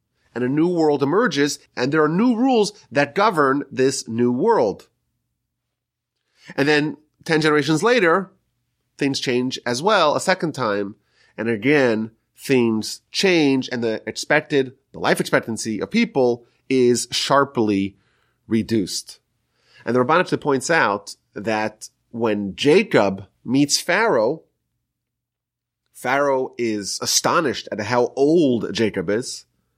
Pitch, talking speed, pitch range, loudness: 130 Hz, 120 wpm, 115-150 Hz, -20 LUFS